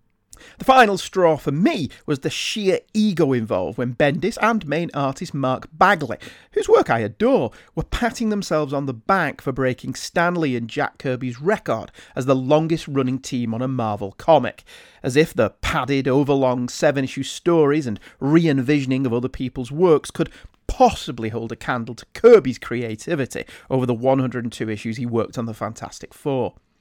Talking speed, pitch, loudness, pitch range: 170 wpm, 135 Hz, -21 LUFS, 125-165 Hz